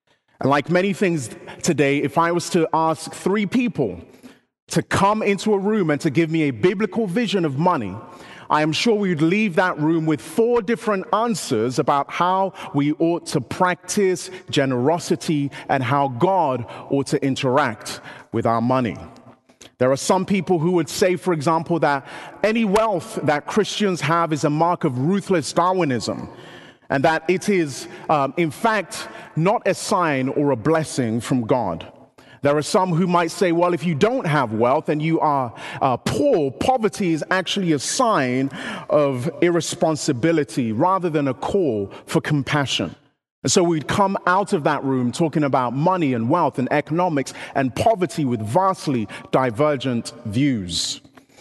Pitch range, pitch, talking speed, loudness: 140-185 Hz, 165 Hz, 165 wpm, -20 LUFS